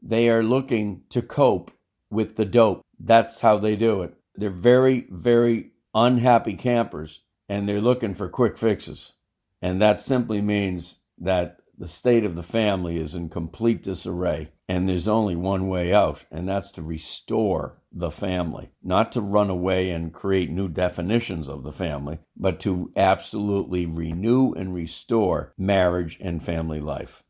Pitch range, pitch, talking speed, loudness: 85-110 Hz, 95 Hz, 155 wpm, -23 LUFS